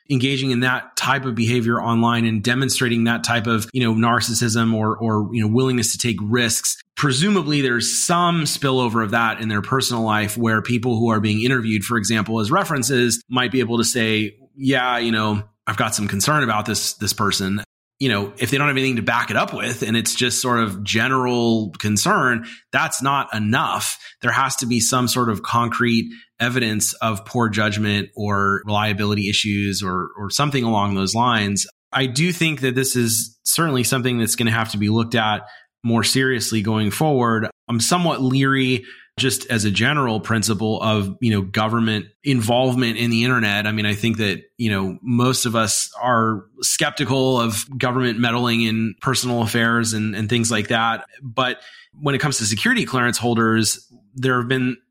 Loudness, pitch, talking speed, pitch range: -19 LUFS, 115 Hz, 190 wpm, 110-125 Hz